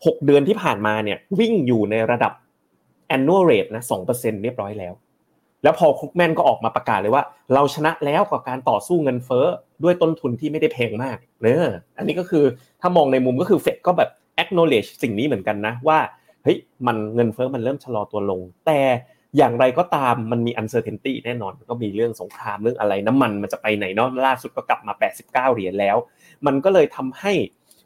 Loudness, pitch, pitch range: -20 LUFS, 125 Hz, 110-150 Hz